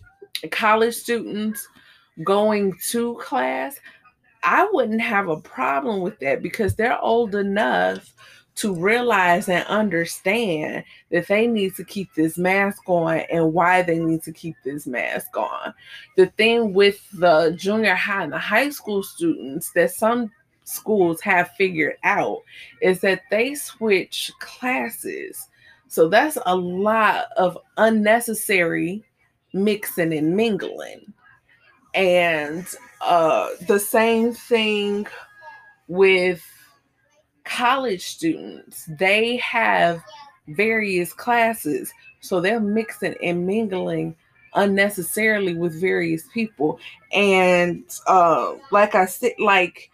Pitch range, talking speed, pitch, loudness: 175-225 Hz, 115 wpm, 200 Hz, -20 LUFS